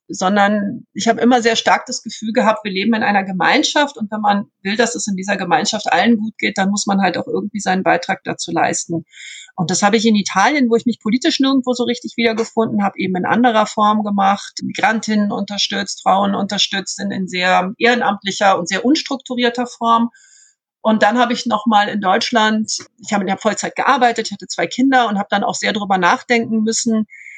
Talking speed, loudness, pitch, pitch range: 205 wpm, -16 LUFS, 215 Hz, 200-240 Hz